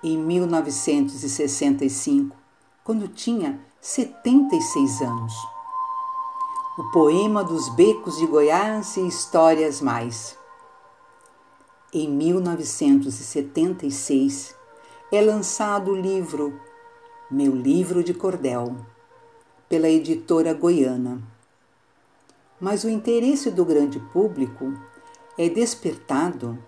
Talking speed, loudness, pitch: 80 wpm, -22 LUFS, 180 Hz